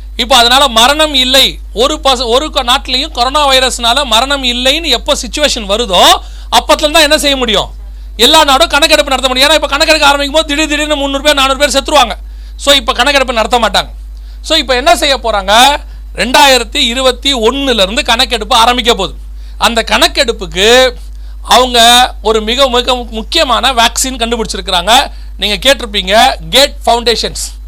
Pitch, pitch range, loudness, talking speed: 260 Hz, 235-285 Hz, -8 LUFS, 140 wpm